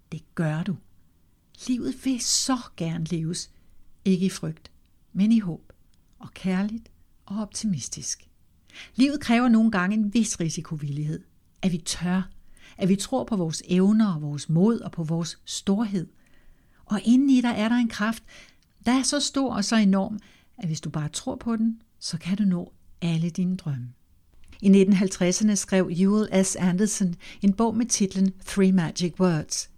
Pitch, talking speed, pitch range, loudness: 190 Hz, 165 wpm, 160-215 Hz, -25 LUFS